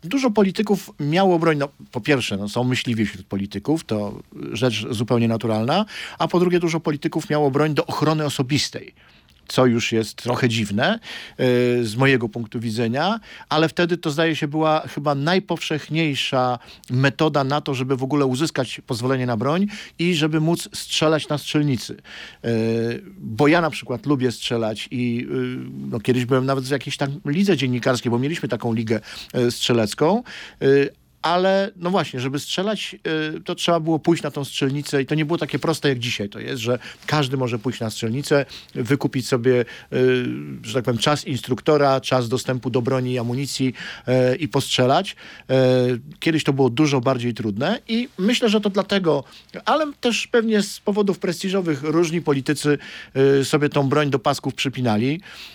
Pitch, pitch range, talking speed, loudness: 140 Hz, 125-160 Hz, 165 wpm, -21 LUFS